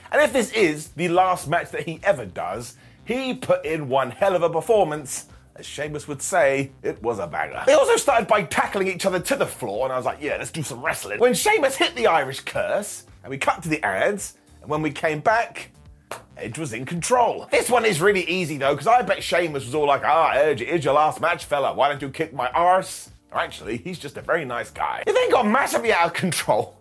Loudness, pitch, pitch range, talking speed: -22 LUFS, 170 Hz, 145-200 Hz, 245 wpm